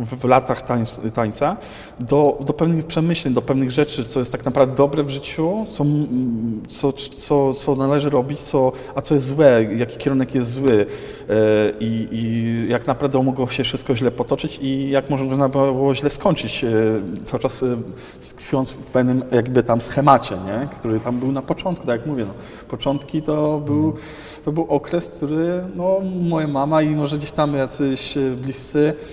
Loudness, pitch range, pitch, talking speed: -20 LUFS, 125-150 Hz, 135 Hz, 175 wpm